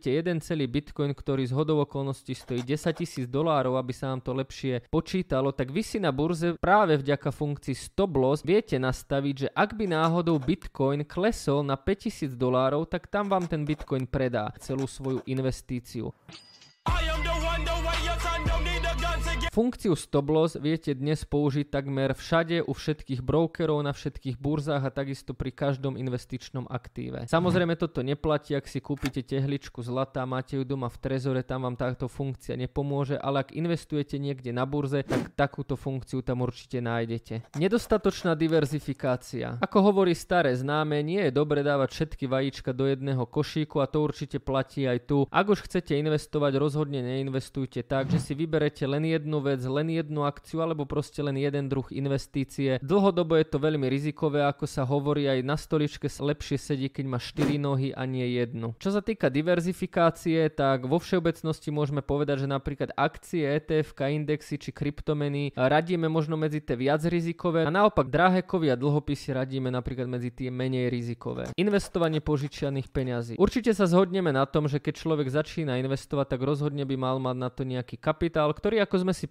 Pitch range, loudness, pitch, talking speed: 135-160 Hz, -28 LUFS, 145 Hz, 165 wpm